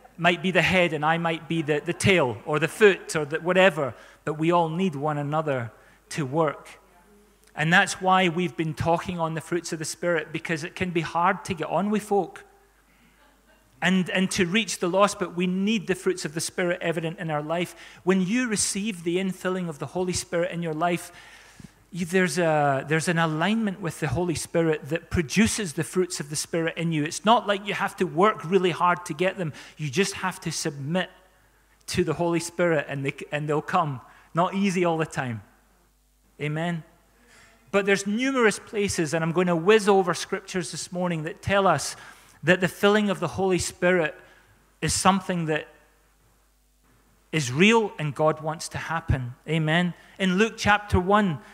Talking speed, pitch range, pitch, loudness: 190 wpm, 160-190 Hz, 175 Hz, -25 LUFS